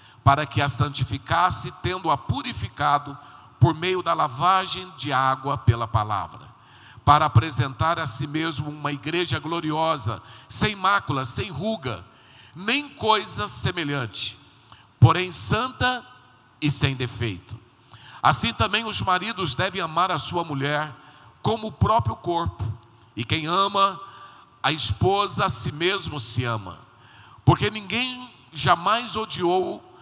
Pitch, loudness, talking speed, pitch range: 145 Hz, -24 LUFS, 120 wpm, 120-180 Hz